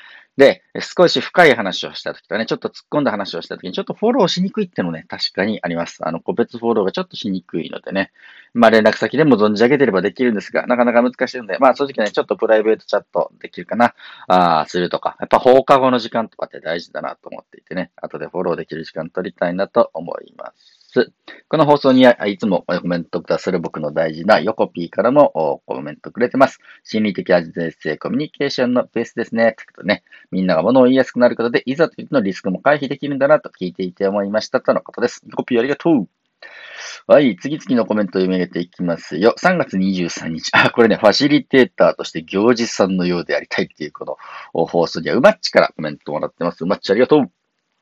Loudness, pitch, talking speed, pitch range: -17 LUFS, 110 Hz, 485 characters per minute, 90-130 Hz